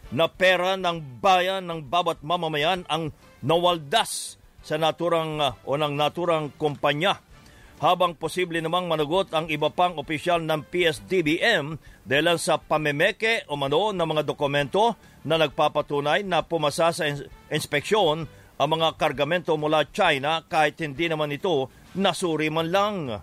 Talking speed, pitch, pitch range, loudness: 130 wpm, 160 Hz, 150-175 Hz, -24 LUFS